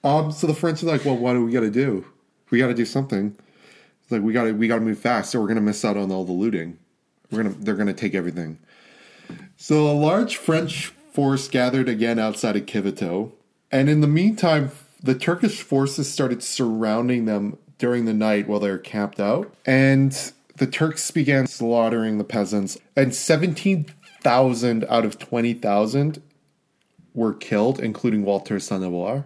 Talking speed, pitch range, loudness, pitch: 180 wpm, 110-145 Hz, -22 LUFS, 125 Hz